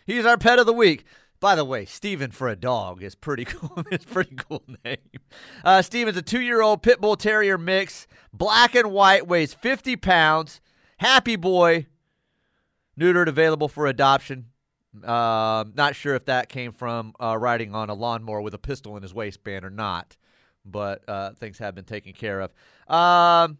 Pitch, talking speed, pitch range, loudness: 145 Hz, 185 wpm, 115-190 Hz, -21 LUFS